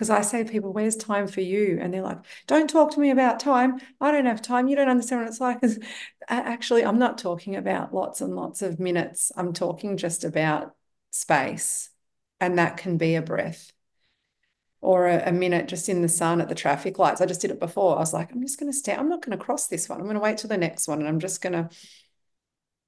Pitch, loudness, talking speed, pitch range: 200 Hz, -24 LUFS, 240 wpm, 175-245 Hz